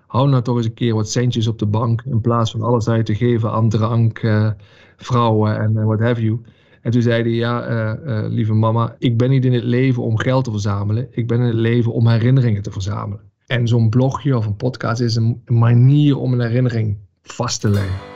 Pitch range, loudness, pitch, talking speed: 110-120 Hz, -17 LUFS, 115 Hz, 230 wpm